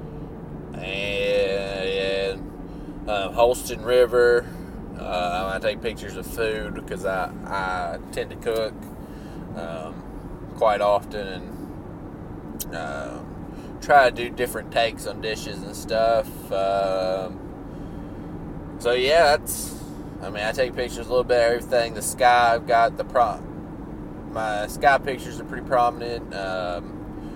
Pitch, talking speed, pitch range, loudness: 105 Hz, 125 wpm, 95-120 Hz, -23 LUFS